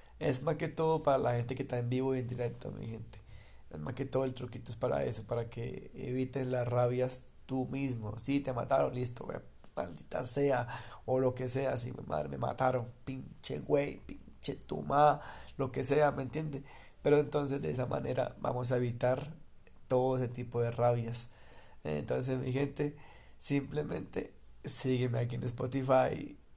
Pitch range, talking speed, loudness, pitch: 120-135 Hz, 175 wpm, -33 LUFS, 130 Hz